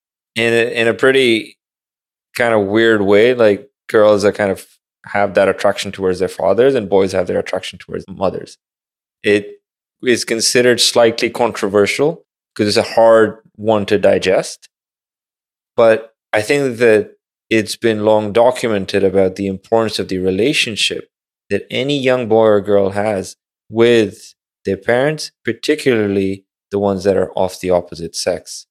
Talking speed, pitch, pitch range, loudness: 150 wpm, 110 Hz, 100-115 Hz, -15 LUFS